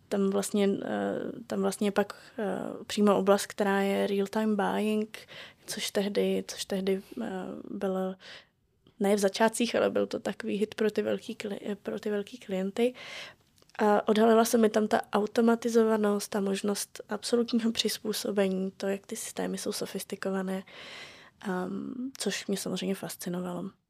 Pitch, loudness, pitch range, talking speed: 205 Hz, -30 LUFS, 195-220 Hz, 130 wpm